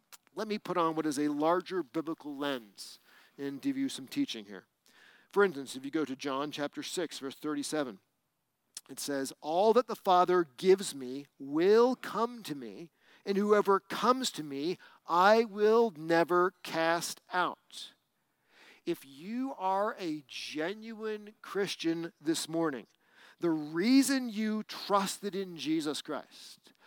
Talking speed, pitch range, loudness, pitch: 145 wpm, 145-210 Hz, -31 LUFS, 170 Hz